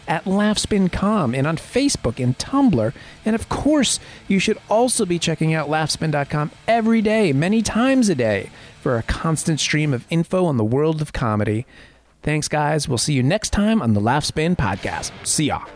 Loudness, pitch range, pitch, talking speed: -20 LUFS, 135-210 Hz, 160 Hz, 180 wpm